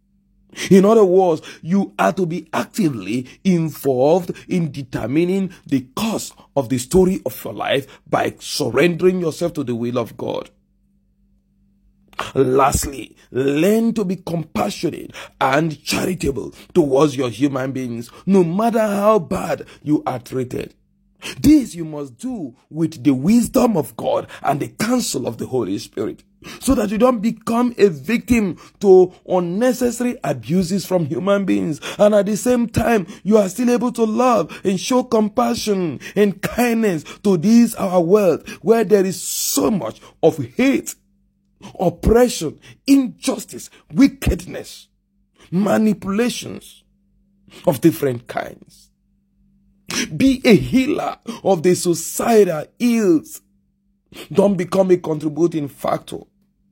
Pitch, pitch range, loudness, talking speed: 190 Hz, 160-220 Hz, -18 LUFS, 125 wpm